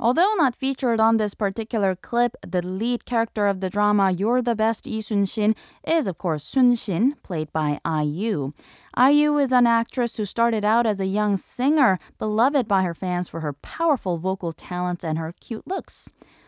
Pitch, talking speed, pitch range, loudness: 215 Hz, 180 wpm, 185-240 Hz, -23 LUFS